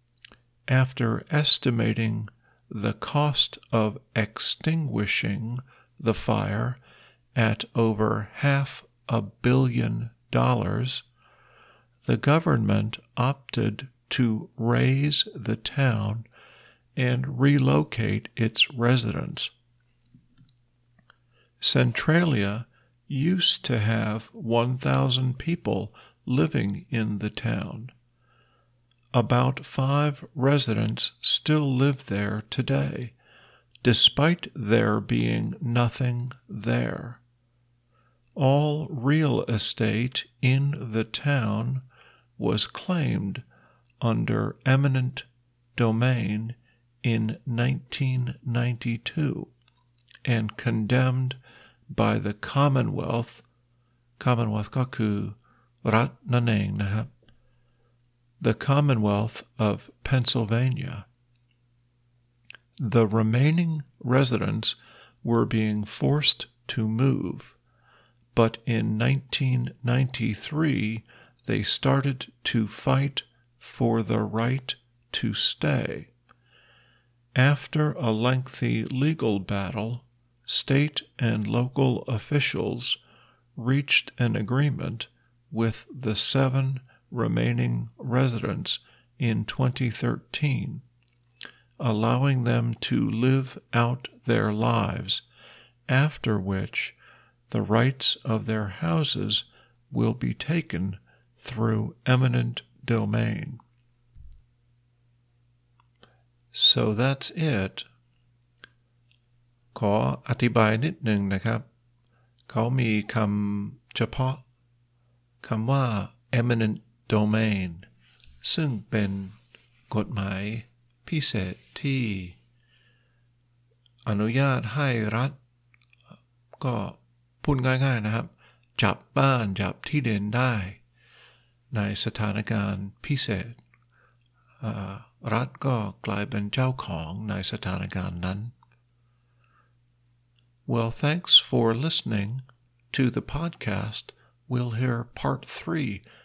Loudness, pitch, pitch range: -25 LUFS, 120 Hz, 110-130 Hz